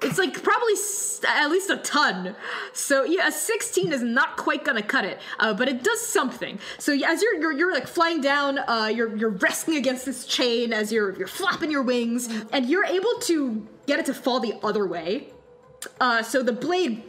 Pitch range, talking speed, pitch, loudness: 235-355 Hz, 210 wpm, 280 Hz, -24 LUFS